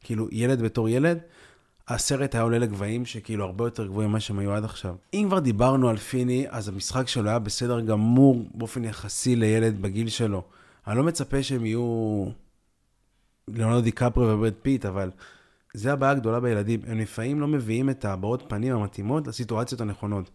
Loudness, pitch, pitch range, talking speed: -26 LUFS, 115 Hz, 105-125 Hz, 170 wpm